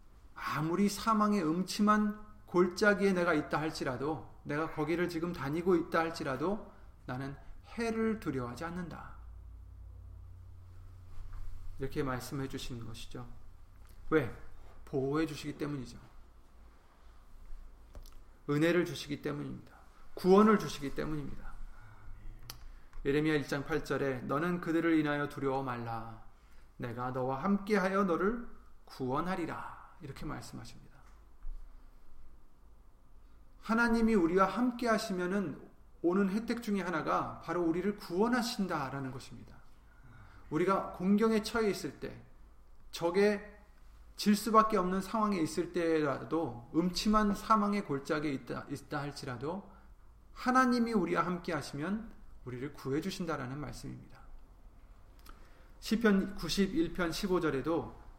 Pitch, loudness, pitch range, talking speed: 155 Hz, -33 LUFS, 115-190 Hz, 265 characters per minute